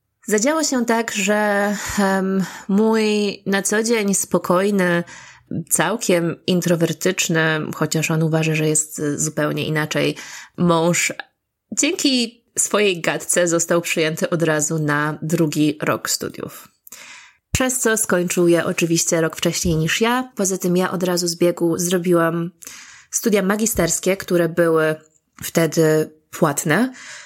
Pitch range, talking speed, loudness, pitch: 160-200 Hz, 120 wpm, -19 LUFS, 175 Hz